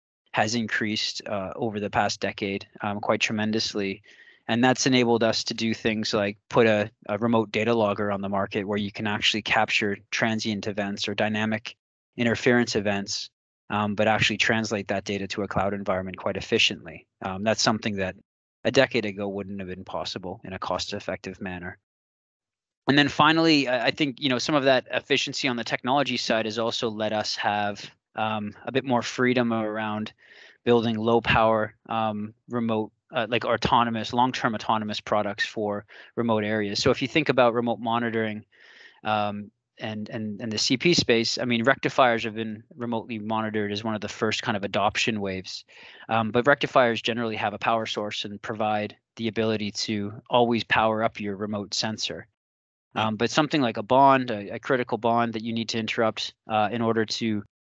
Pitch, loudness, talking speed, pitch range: 110 Hz, -25 LUFS, 180 wpm, 105-120 Hz